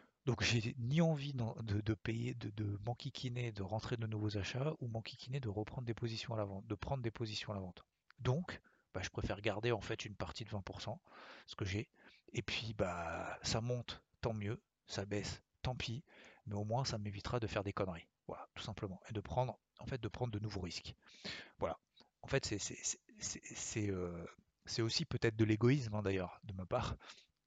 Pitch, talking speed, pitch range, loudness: 115 Hz, 210 wpm, 105-125 Hz, -41 LUFS